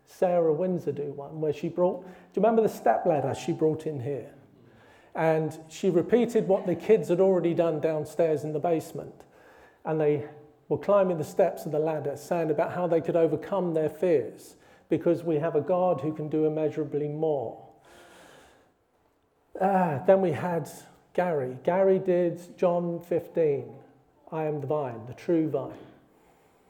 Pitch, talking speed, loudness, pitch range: 165 Hz, 165 wpm, -27 LUFS, 150-180 Hz